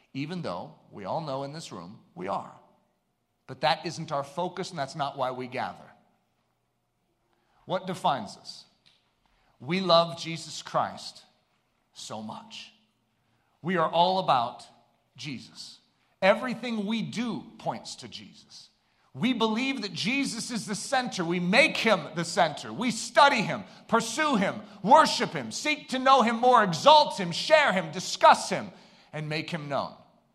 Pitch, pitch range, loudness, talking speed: 185 Hz, 160-230 Hz, -26 LUFS, 150 wpm